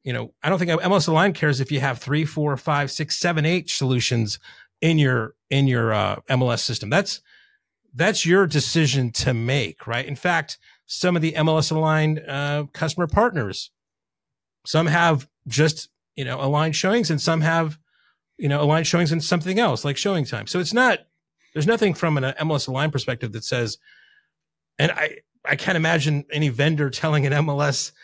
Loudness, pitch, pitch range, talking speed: -21 LUFS, 150 Hz, 135-165 Hz, 180 wpm